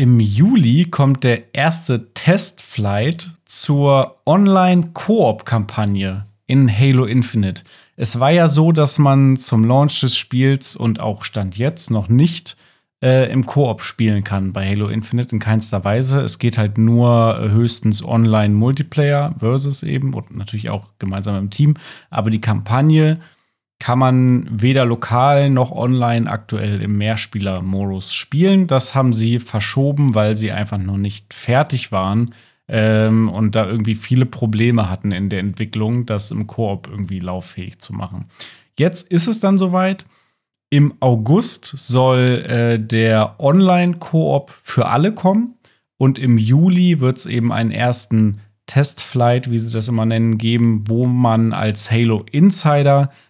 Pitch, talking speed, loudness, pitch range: 120 Hz, 145 wpm, -16 LUFS, 110-140 Hz